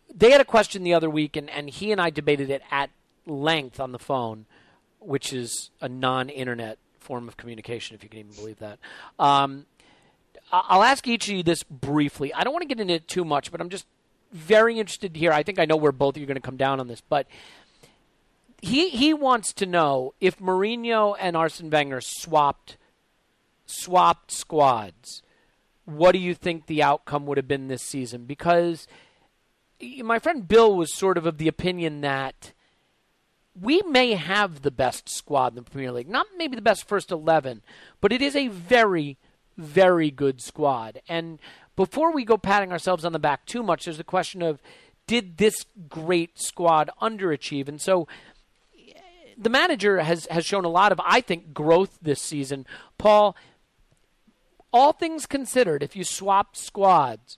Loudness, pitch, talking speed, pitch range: -23 LUFS, 165 Hz, 185 wpm, 140-205 Hz